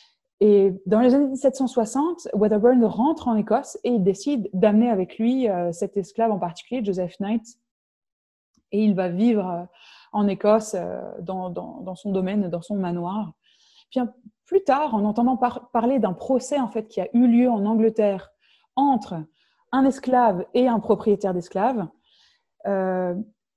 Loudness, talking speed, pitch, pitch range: -22 LUFS, 165 wpm, 220 Hz, 195-250 Hz